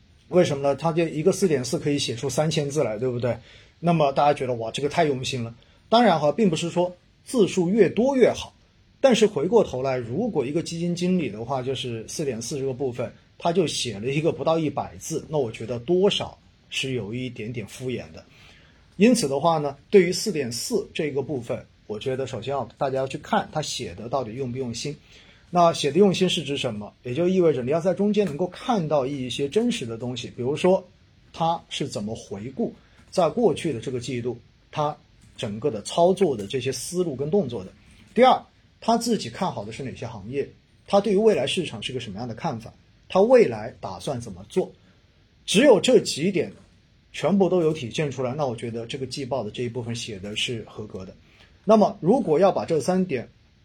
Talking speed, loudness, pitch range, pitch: 305 characters per minute, -24 LUFS, 125-175 Hz, 140 Hz